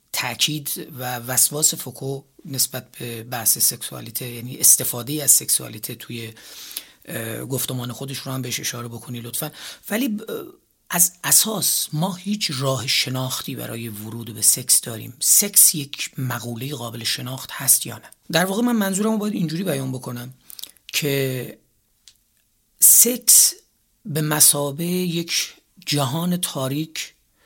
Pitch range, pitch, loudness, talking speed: 120-165 Hz, 135 Hz, -19 LUFS, 125 wpm